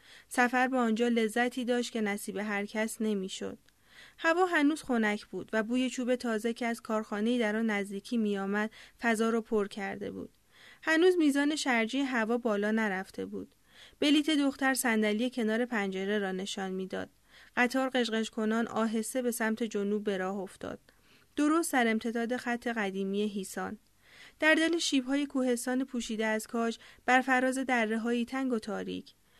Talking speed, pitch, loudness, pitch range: 150 wpm, 230 Hz, -30 LUFS, 210-255 Hz